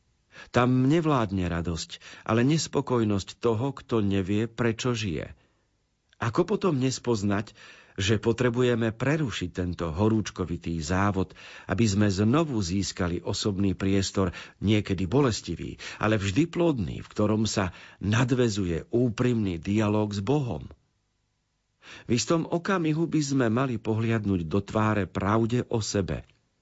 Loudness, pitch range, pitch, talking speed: -27 LUFS, 100-125 Hz, 110 Hz, 115 wpm